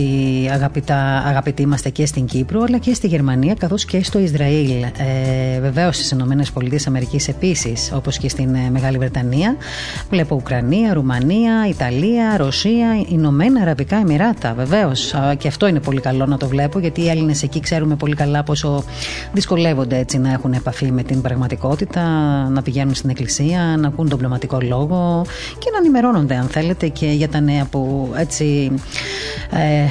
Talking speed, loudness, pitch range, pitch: 160 wpm, -17 LUFS, 135-165 Hz, 145 Hz